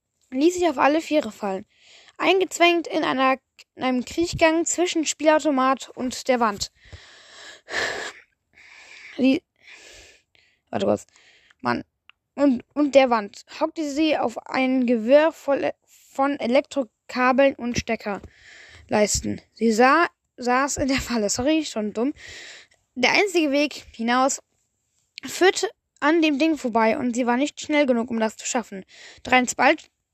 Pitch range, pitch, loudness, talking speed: 245-315 Hz, 275 Hz, -22 LUFS, 125 wpm